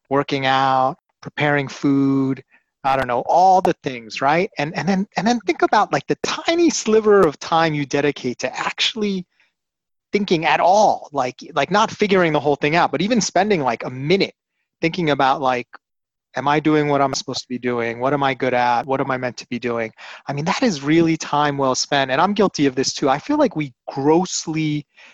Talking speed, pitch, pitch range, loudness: 215 wpm, 145 Hz, 135-185 Hz, -19 LUFS